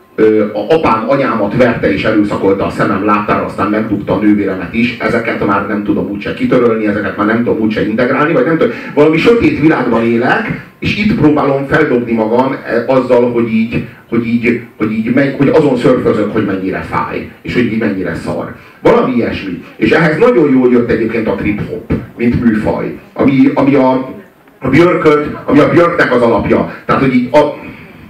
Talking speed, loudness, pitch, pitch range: 180 wpm, -12 LUFS, 120 Hz, 105-140 Hz